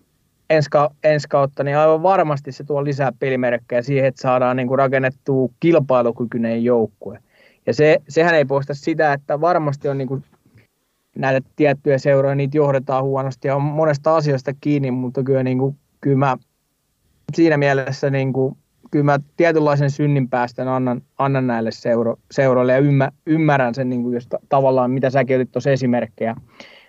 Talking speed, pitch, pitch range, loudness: 150 wpm, 135 Hz, 130-145 Hz, -18 LUFS